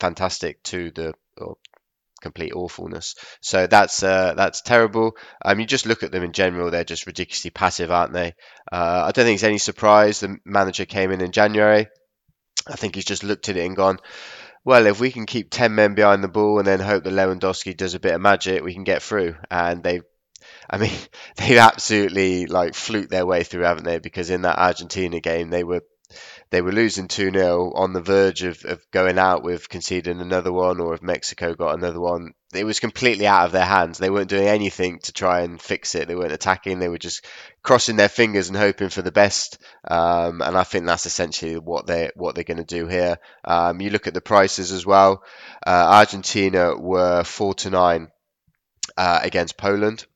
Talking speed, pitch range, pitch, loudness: 210 wpm, 90-100 Hz, 95 Hz, -20 LUFS